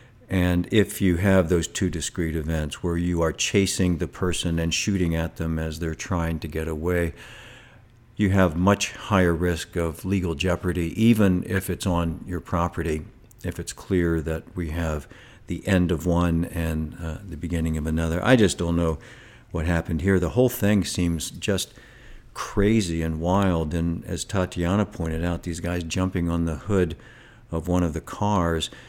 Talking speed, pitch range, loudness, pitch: 175 wpm, 85-95 Hz, -24 LUFS, 85 Hz